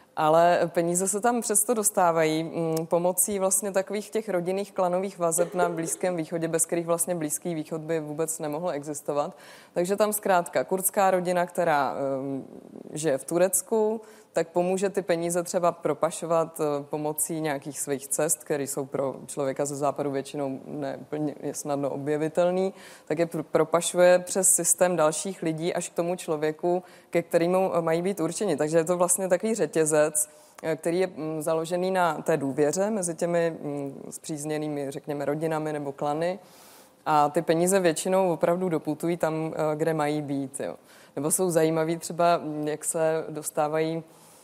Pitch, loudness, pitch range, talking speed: 165 Hz, -26 LUFS, 150-180 Hz, 145 wpm